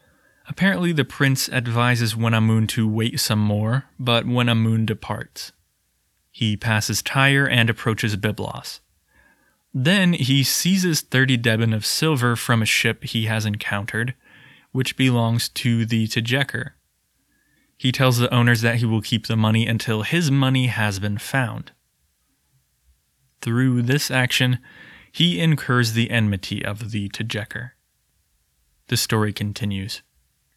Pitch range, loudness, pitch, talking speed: 110-130 Hz, -20 LUFS, 115 Hz, 130 wpm